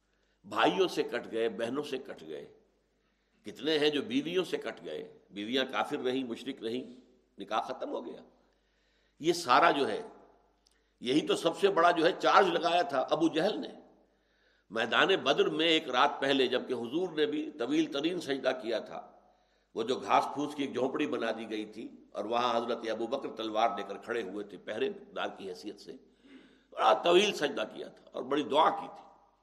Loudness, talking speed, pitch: -31 LUFS, 190 wpm, 150 Hz